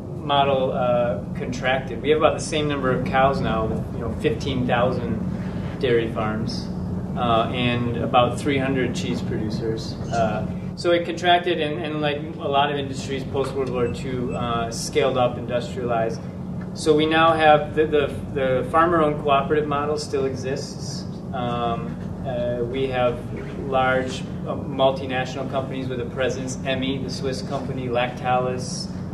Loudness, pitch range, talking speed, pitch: -23 LUFS, 125-150 Hz, 140 wpm, 135 Hz